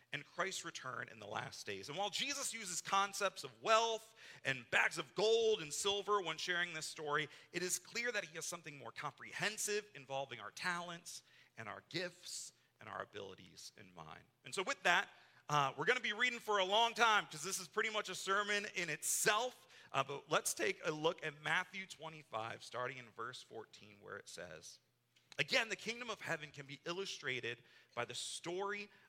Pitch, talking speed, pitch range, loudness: 180 Hz, 195 wpm, 150-210 Hz, -39 LUFS